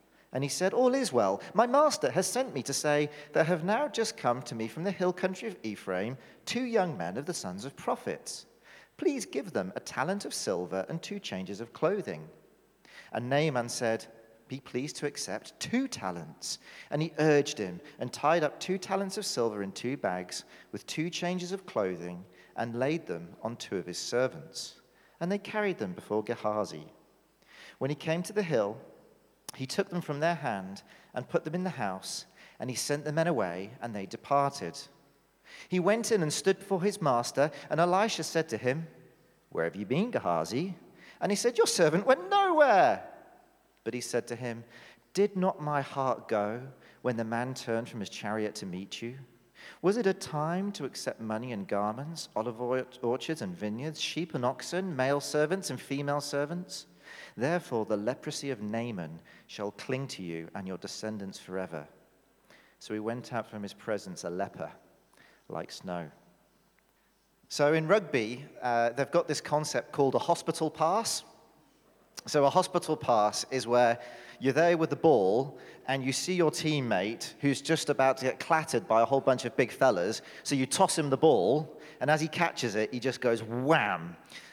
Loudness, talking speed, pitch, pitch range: -31 LUFS, 185 wpm, 140 Hz, 115-170 Hz